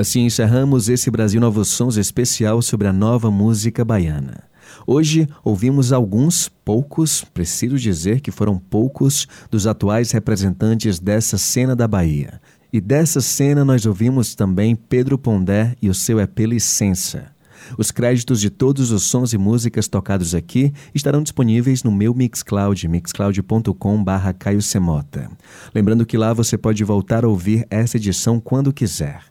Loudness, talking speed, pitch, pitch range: -17 LUFS, 145 wpm, 115 Hz, 100-125 Hz